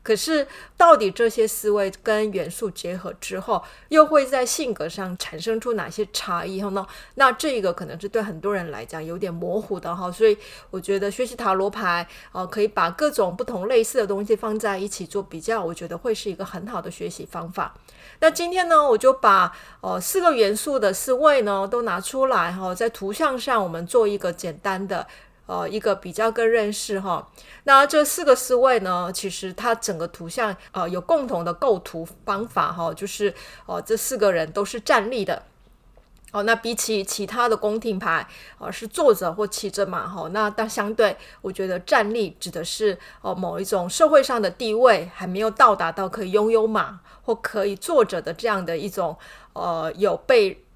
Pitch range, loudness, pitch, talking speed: 185-235 Hz, -22 LUFS, 205 Hz, 285 characters per minute